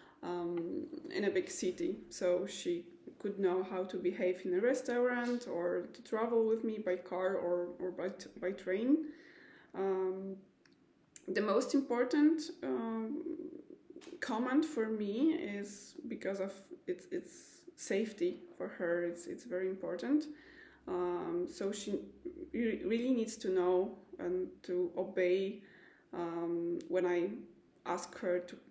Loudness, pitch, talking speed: -37 LUFS, 225 Hz, 135 wpm